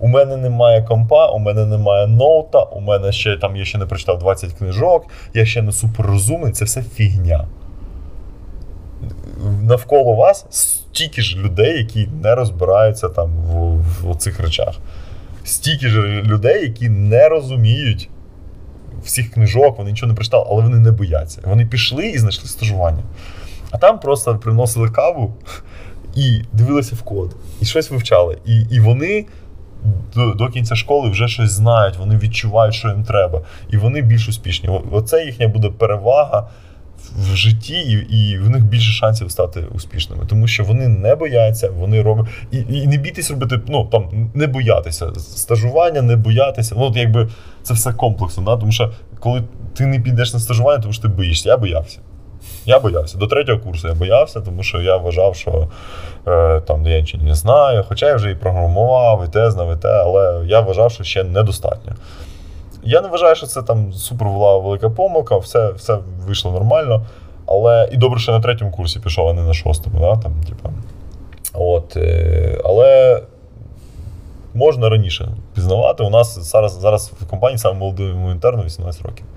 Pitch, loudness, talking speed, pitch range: 105 Hz, -15 LUFS, 165 wpm, 90-115 Hz